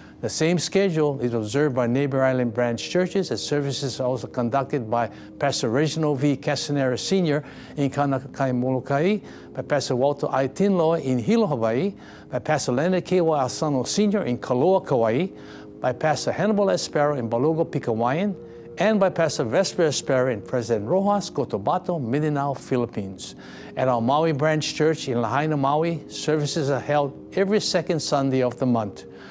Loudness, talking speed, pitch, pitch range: -23 LUFS, 155 wpm, 145 Hz, 125-165 Hz